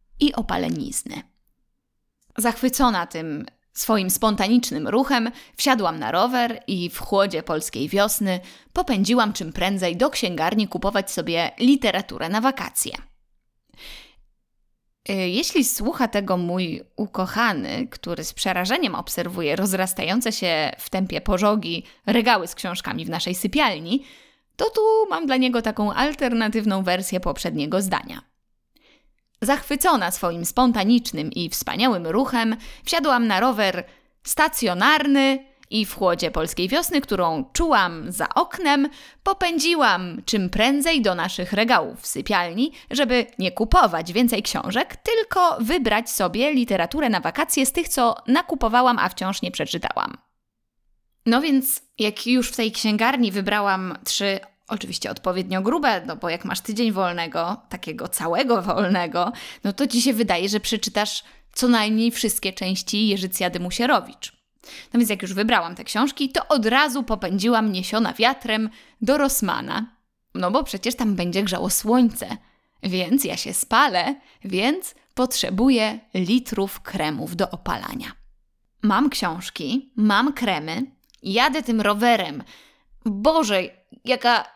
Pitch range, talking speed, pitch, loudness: 190-260 Hz, 125 wpm, 225 Hz, -22 LUFS